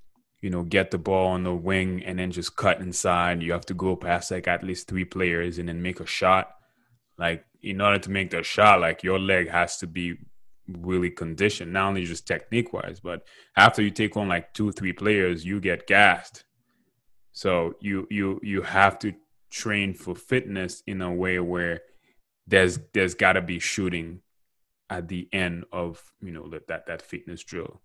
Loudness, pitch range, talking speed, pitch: -24 LUFS, 90-100 Hz, 195 wpm, 90 Hz